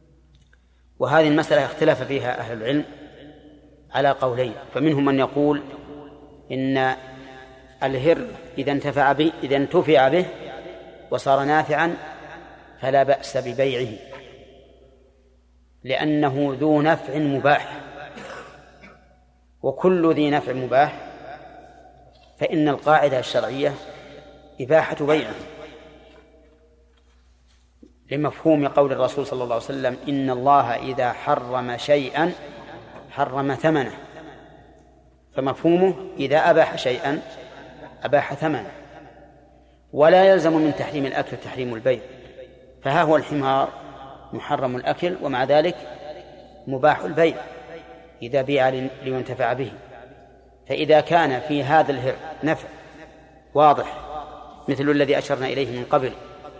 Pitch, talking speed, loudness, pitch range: 140 Hz, 95 wpm, -21 LUFS, 130-155 Hz